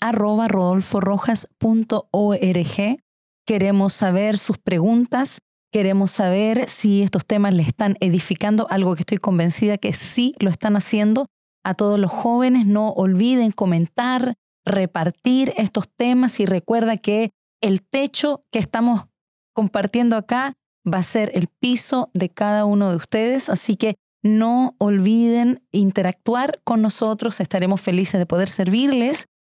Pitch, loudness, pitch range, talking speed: 210 Hz, -20 LUFS, 195-235 Hz, 130 wpm